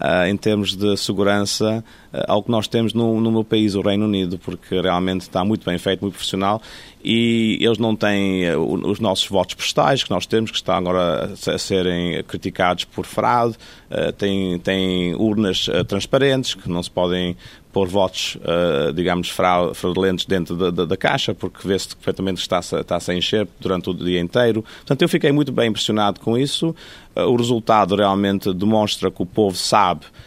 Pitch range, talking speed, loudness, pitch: 90-110 Hz, 180 wpm, -19 LUFS, 100 Hz